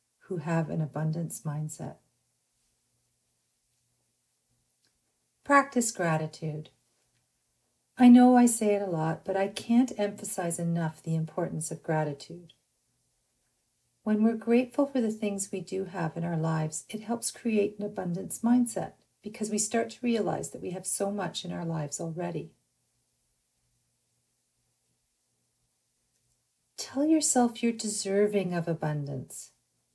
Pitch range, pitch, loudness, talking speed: 155-215 Hz, 185 Hz, -28 LUFS, 120 wpm